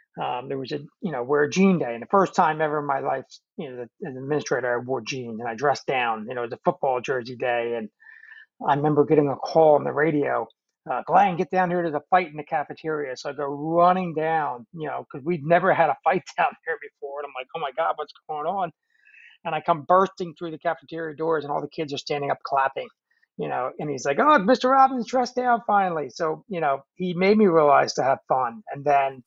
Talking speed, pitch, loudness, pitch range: 250 wpm, 160 Hz, -24 LUFS, 145-190 Hz